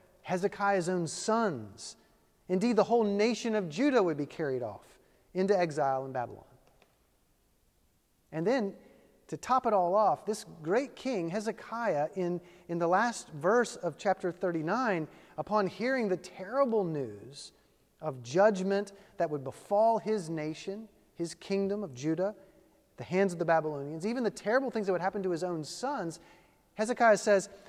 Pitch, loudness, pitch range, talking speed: 195 Hz, -31 LUFS, 170-215 Hz, 150 wpm